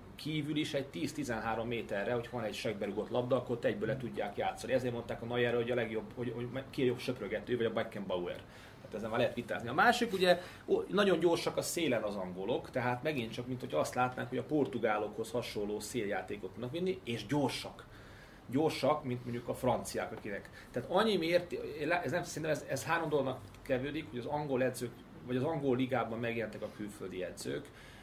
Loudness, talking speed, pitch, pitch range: -35 LUFS, 190 wpm, 125 Hz, 115-150 Hz